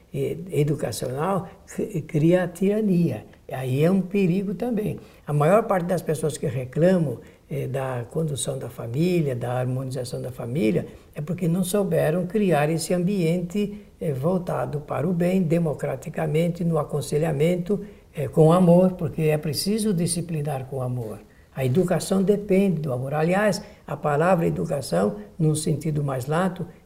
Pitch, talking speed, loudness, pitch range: 160 Hz, 140 wpm, -24 LUFS, 145-185 Hz